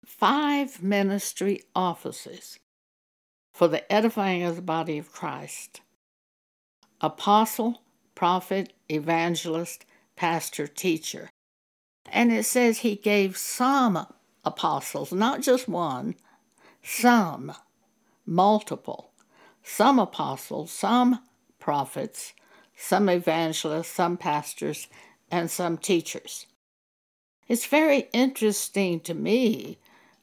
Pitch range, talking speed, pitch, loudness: 170-235 Hz, 85 wpm, 195 Hz, -25 LUFS